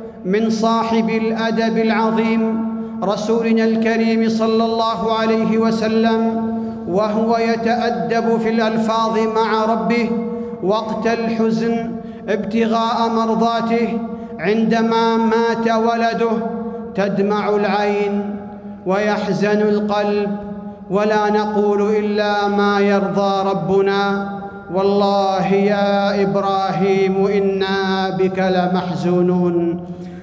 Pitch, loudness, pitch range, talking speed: 220 Hz, -17 LUFS, 200-225 Hz, 75 wpm